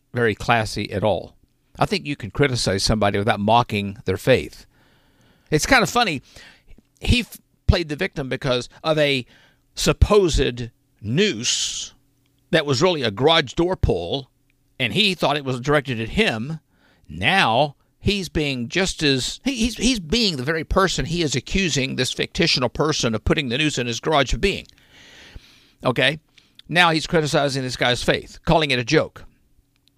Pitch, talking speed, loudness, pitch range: 140 Hz, 160 wpm, -20 LUFS, 125-165 Hz